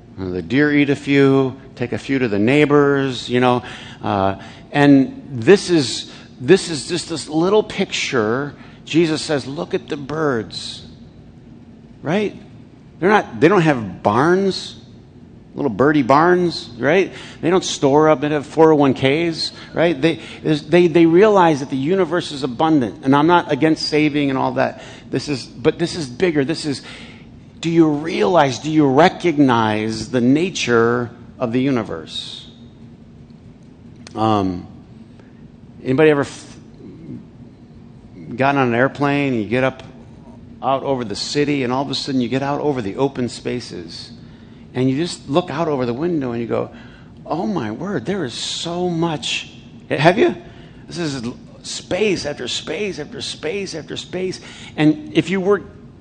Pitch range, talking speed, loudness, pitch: 125-160 Hz, 155 wpm, -18 LUFS, 140 Hz